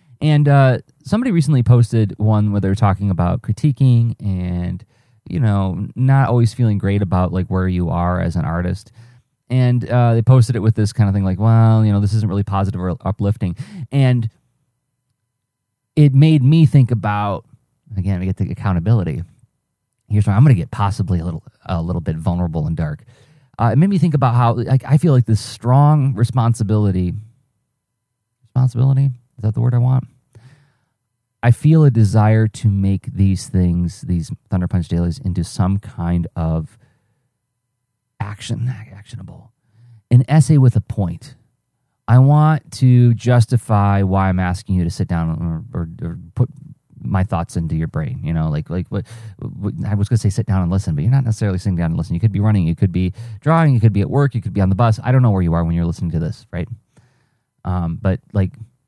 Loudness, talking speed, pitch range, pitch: -17 LUFS, 195 wpm, 95-125 Hz, 110 Hz